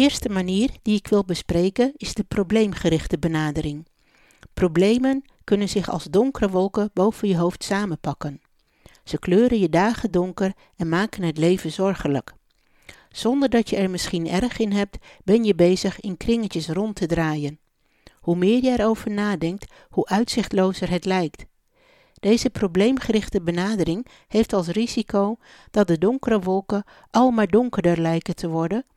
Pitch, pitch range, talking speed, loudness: 200 Hz, 175-220 Hz, 150 wpm, -22 LUFS